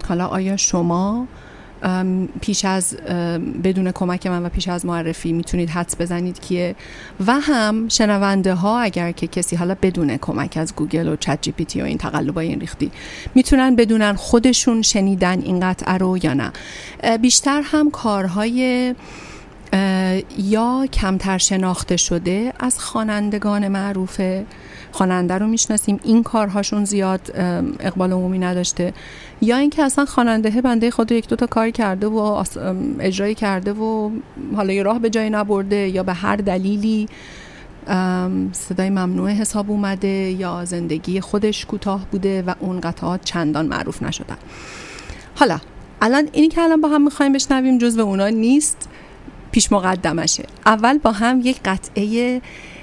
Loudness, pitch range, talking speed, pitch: -19 LUFS, 180-225 Hz, 140 wpm, 195 Hz